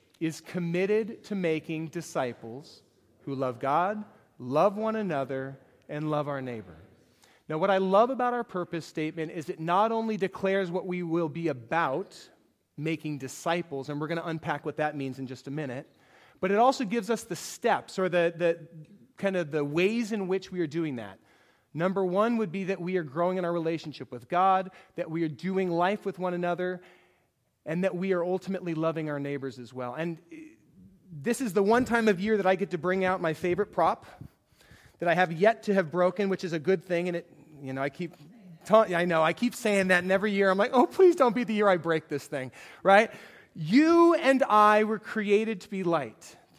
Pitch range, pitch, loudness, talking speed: 155-200 Hz, 175 Hz, -28 LUFS, 210 wpm